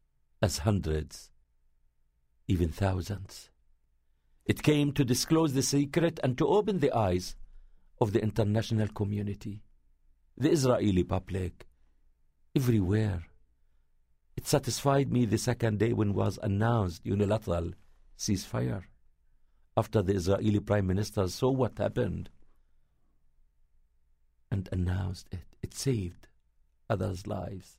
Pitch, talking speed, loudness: 95 Hz, 105 wpm, -30 LUFS